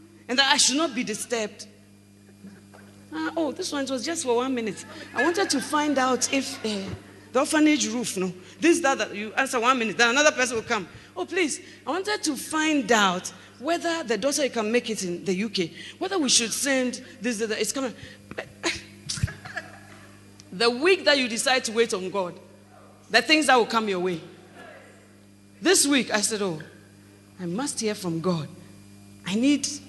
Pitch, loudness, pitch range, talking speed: 230 Hz, -24 LUFS, 175-275 Hz, 185 wpm